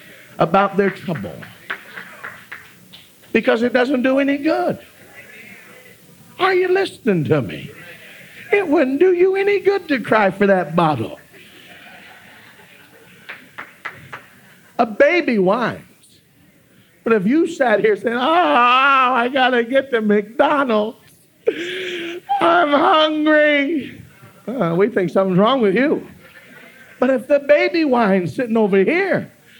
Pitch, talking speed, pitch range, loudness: 265 Hz, 115 wpm, 215-320 Hz, -17 LUFS